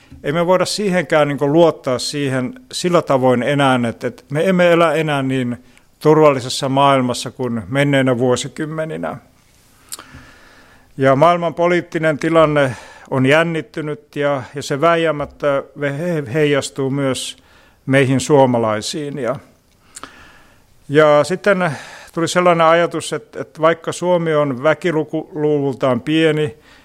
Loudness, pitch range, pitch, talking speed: -16 LUFS, 135-160 Hz, 145 Hz, 110 wpm